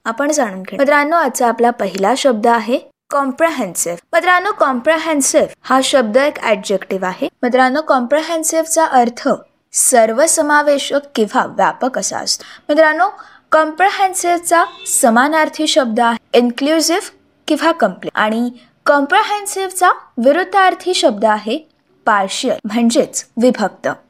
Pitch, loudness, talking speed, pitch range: 285 Hz, -14 LUFS, 105 wpm, 240-325 Hz